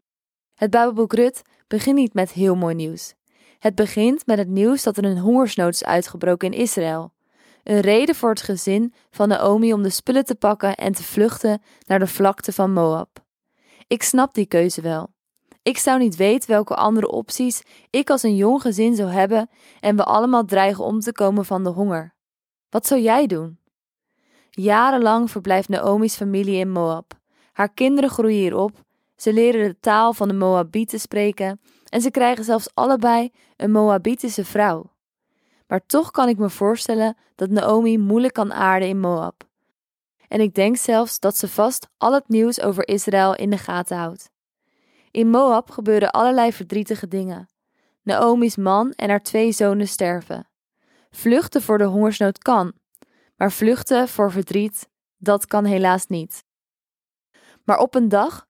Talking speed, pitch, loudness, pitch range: 165 wpm, 210 Hz, -19 LUFS, 195-235 Hz